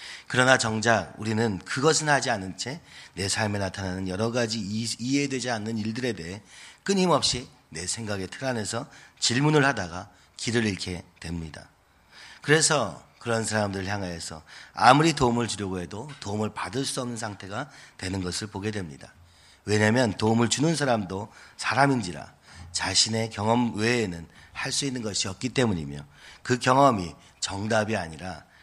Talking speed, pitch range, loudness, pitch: 325 characters per minute, 95-125 Hz, -26 LUFS, 110 Hz